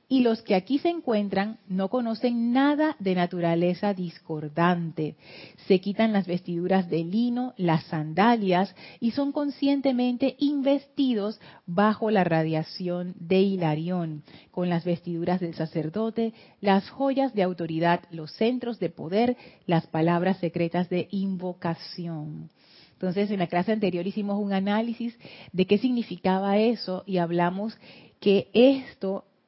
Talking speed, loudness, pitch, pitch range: 130 wpm, -26 LUFS, 195 Hz, 175-230 Hz